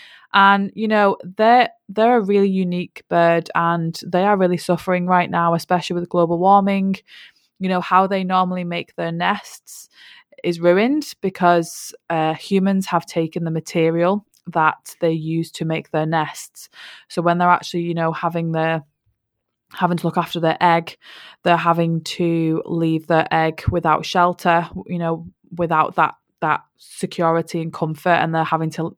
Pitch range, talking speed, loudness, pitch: 165-185 Hz, 160 wpm, -19 LUFS, 170 Hz